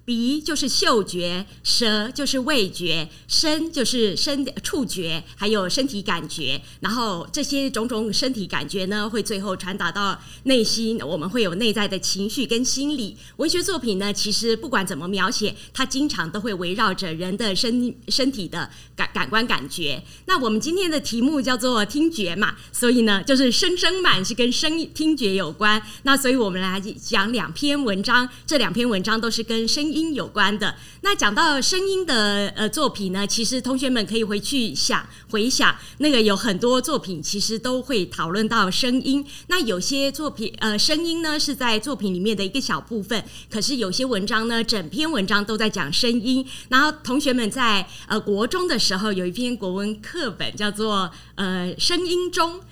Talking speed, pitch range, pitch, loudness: 270 characters per minute, 200-265 Hz, 225 Hz, -22 LUFS